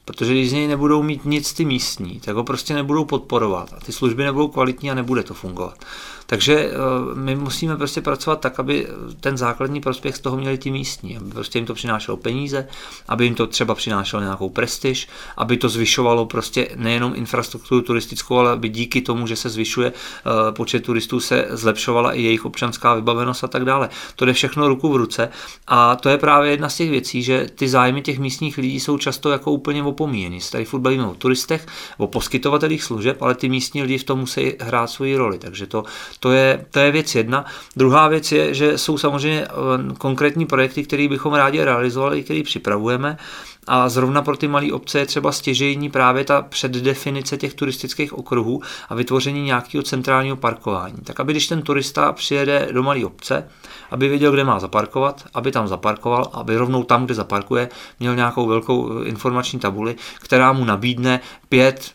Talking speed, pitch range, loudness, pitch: 185 wpm, 120-140 Hz, -19 LUFS, 130 Hz